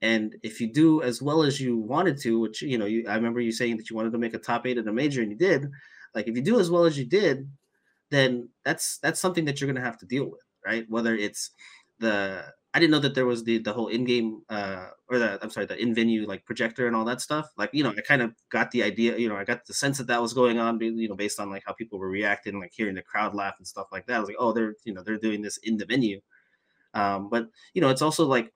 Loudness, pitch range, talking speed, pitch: -26 LUFS, 110-125 Hz, 290 wpm, 115 Hz